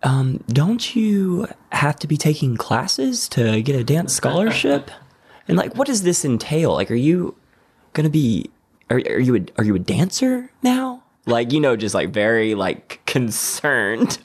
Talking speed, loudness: 175 wpm, -19 LUFS